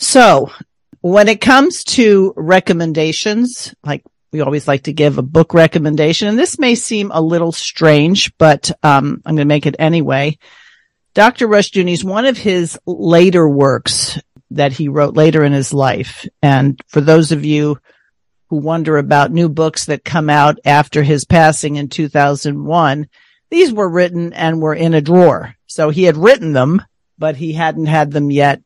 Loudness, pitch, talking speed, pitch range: -12 LUFS, 160 Hz, 170 wpm, 150-180 Hz